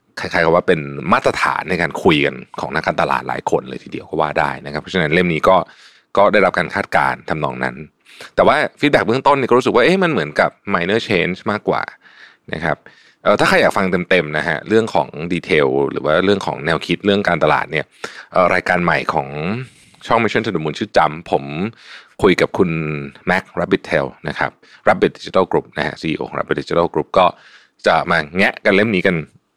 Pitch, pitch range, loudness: 80 Hz, 75-95 Hz, -17 LUFS